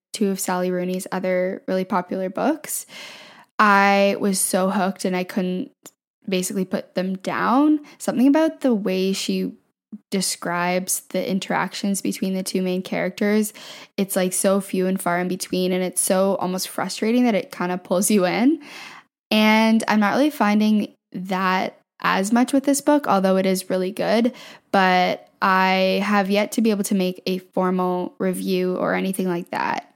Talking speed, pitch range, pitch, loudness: 170 wpm, 185-215 Hz, 190 Hz, -21 LUFS